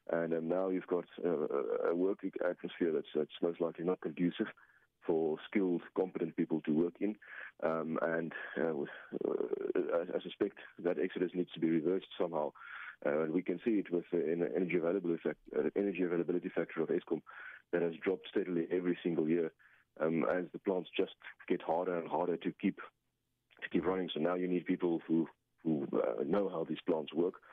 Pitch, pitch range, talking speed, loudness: 90 Hz, 85-95 Hz, 195 wpm, -36 LUFS